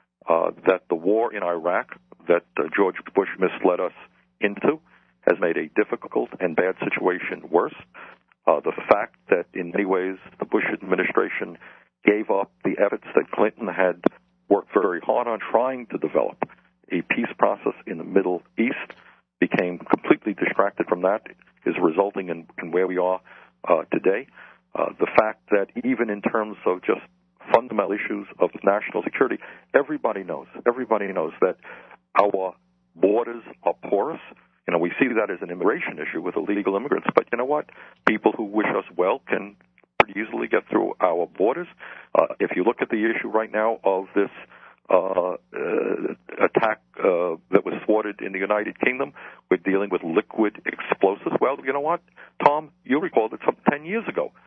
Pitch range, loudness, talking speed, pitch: 95-130 Hz, -24 LUFS, 170 wpm, 100 Hz